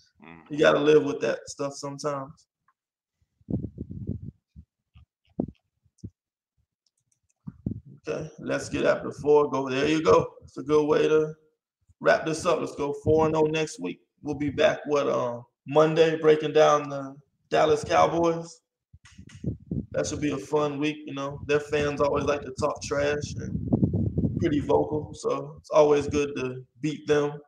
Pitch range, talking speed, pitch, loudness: 140-155 Hz, 150 wpm, 145 Hz, -25 LUFS